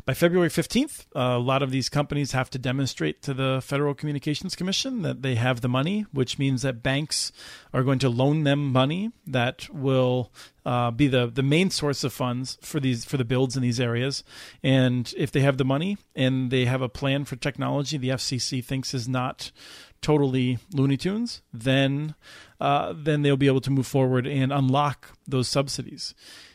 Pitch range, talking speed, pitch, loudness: 130-145 Hz, 190 wpm, 135 Hz, -25 LUFS